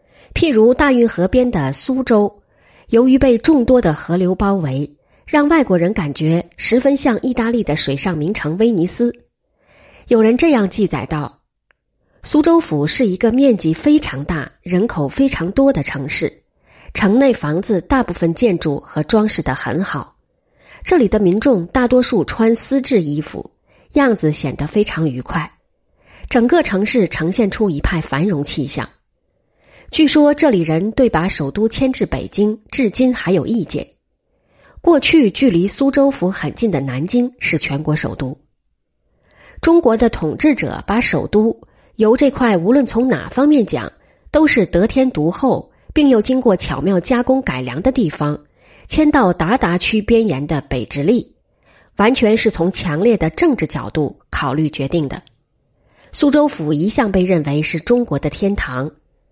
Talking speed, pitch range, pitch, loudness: 230 characters per minute, 160-255 Hz, 210 Hz, -15 LUFS